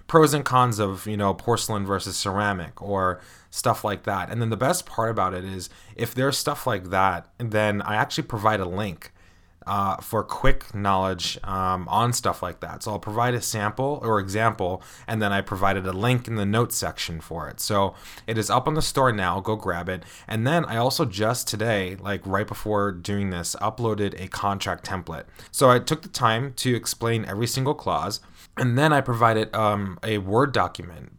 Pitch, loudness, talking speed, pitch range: 105 Hz, -24 LUFS, 200 wpm, 95-120 Hz